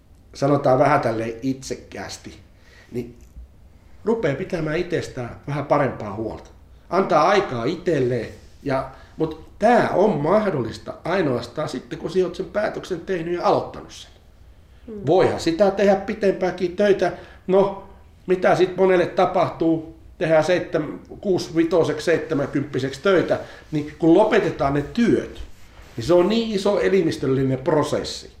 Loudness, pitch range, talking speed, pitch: -21 LUFS, 115-185 Hz, 115 wpm, 155 Hz